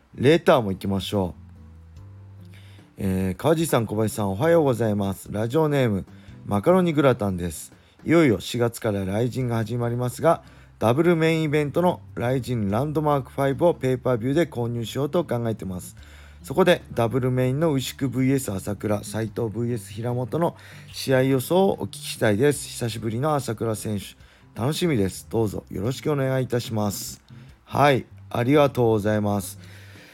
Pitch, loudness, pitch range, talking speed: 120 Hz, -23 LUFS, 100-135 Hz, 365 characters per minute